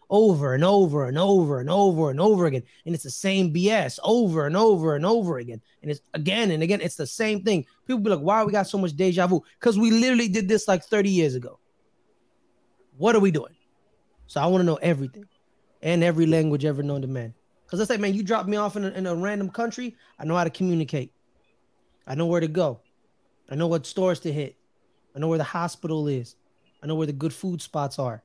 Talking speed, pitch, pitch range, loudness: 235 wpm, 170 Hz, 150-200 Hz, -24 LUFS